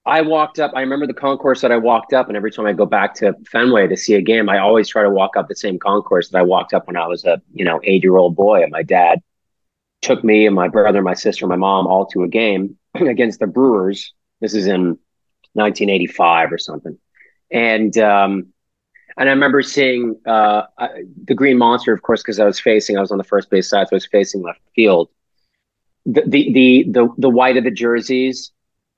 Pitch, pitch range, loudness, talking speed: 110 Hz, 100-130 Hz, -15 LUFS, 230 wpm